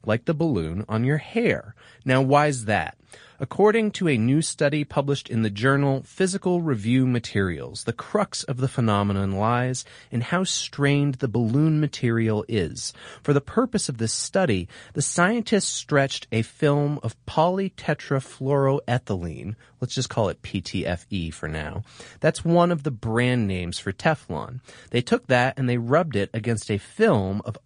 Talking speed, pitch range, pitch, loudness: 160 wpm, 110-150 Hz, 125 Hz, -24 LUFS